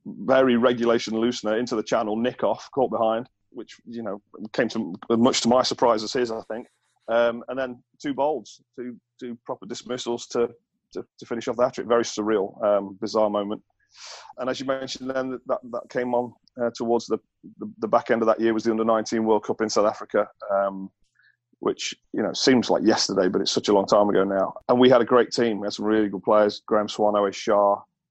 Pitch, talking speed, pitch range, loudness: 115 Hz, 220 wpm, 105-125 Hz, -23 LUFS